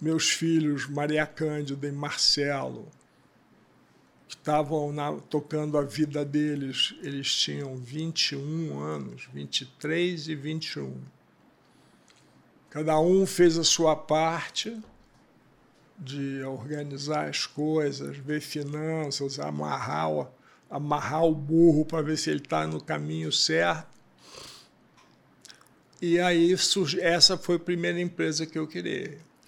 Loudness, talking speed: -27 LUFS, 110 wpm